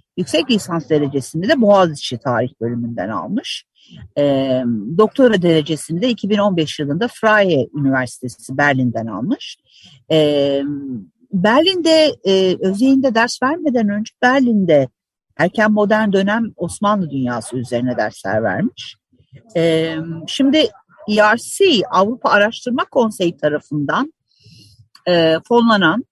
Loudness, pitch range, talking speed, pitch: -16 LUFS, 140-220 Hz, 100 wpm, 175 Hz